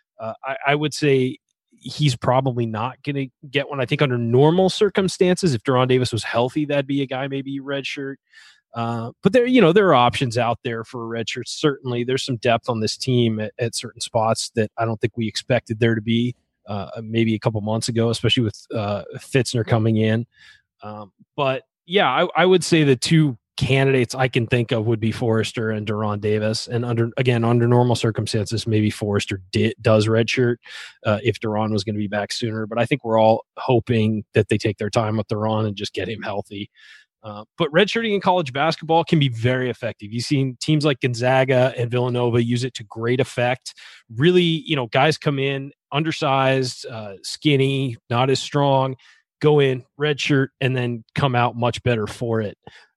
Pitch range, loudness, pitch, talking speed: 115-135 Hz, -21 LUFS, 120 Hz, 200 wpm